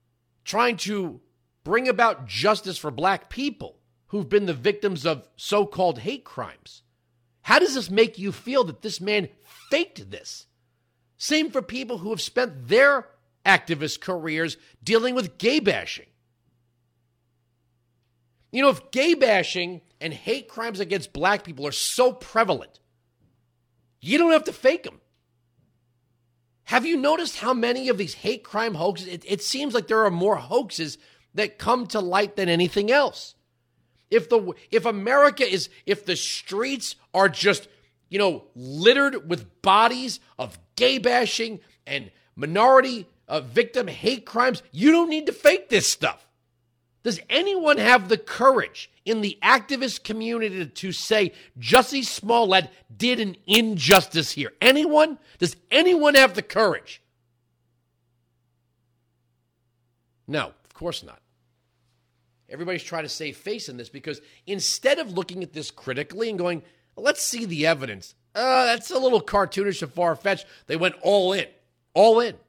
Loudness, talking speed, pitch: -22 LUFS, 150 wpm, 195 Hz